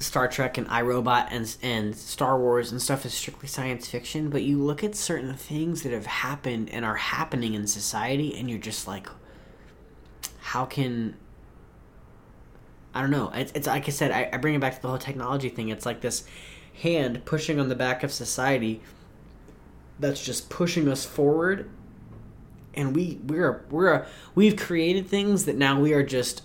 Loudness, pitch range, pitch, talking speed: -26 LUFS, 115-145 Hz, 130 Hz, 180 wpm